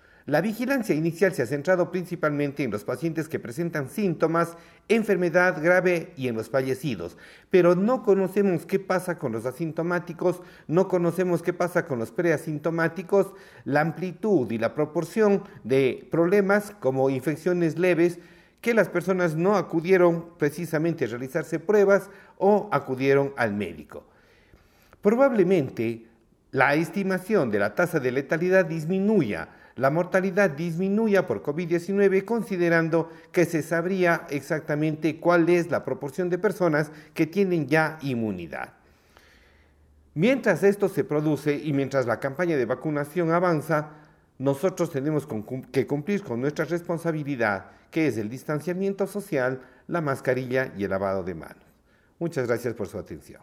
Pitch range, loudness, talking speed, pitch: 140-185 Hz, -25 LUFS, 135 wpm, 165 Hz